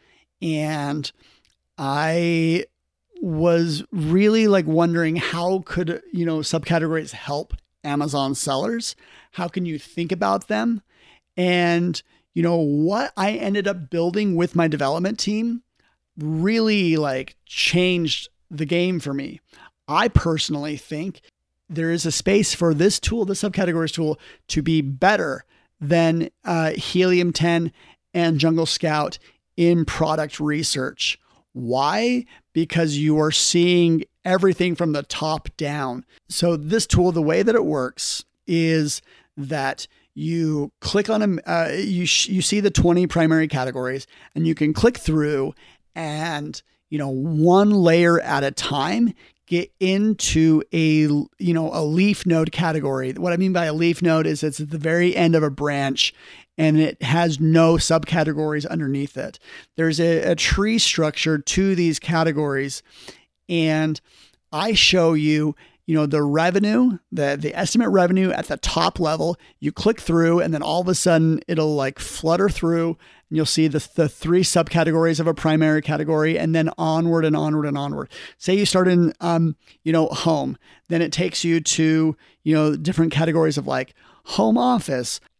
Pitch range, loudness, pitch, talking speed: 155-175 Hz, -20 LUFS, 165 Hz, 155 wpm